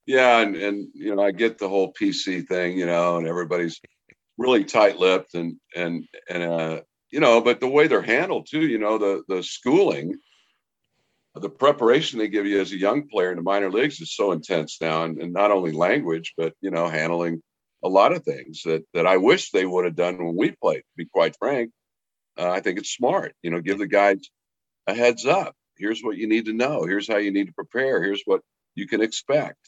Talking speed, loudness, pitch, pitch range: 220 wpm, -22 LUFS, 95 Hz, 85-110 Hz